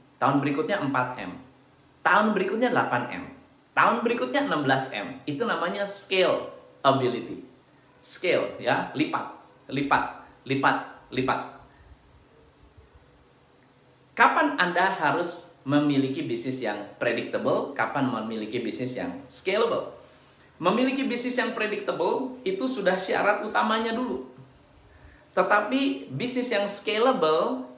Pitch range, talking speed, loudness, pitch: 135-220 Hz, 95 wpm, -26 LUFS, 180 Hz